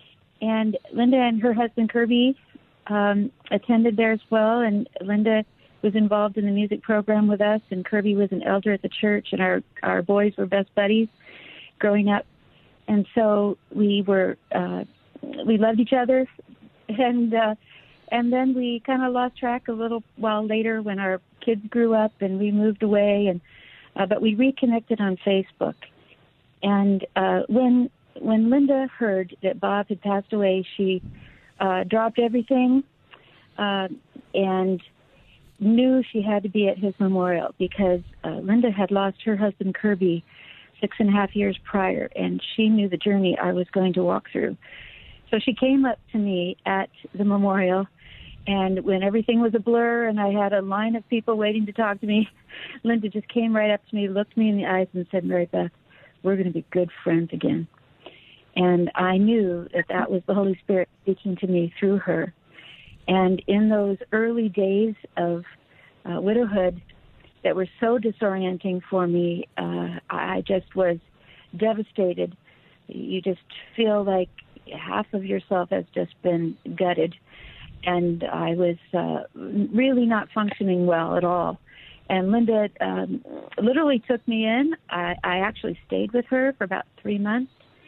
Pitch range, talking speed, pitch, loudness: 185-225 Hz, 170 wpm, 205 Hz, -23 LUFS